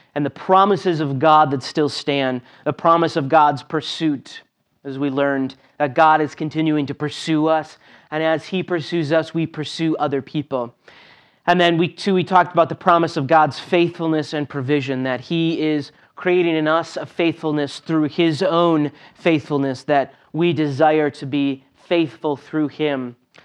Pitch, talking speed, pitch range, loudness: 155 Hz, 170 wpm, 145-165 Hz, -19 LUFS